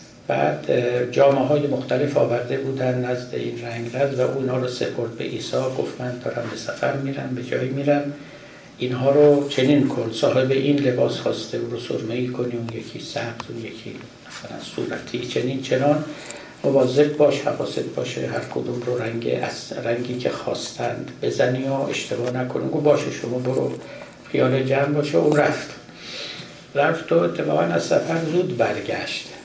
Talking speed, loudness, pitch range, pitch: 160 wpm, -22 LUFS, 125-145 Hz, 135 Hz